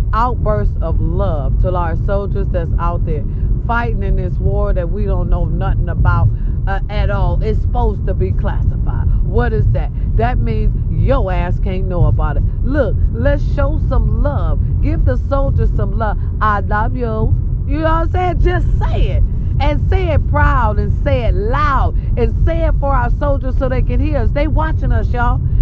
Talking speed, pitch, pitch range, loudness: 190 wpm, 105 Hz, 95-110 Hz, -17 LUFS